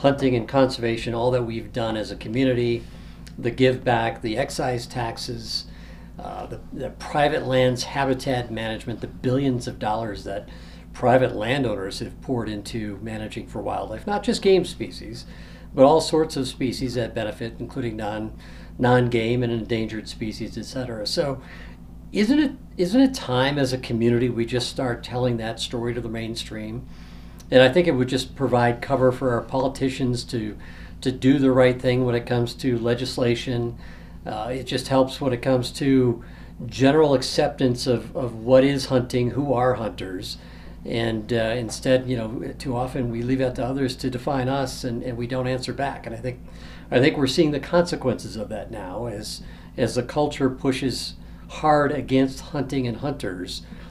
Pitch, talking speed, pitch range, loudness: 125 Hz, 175 wpm, 115-130 Hz, -23 LUFS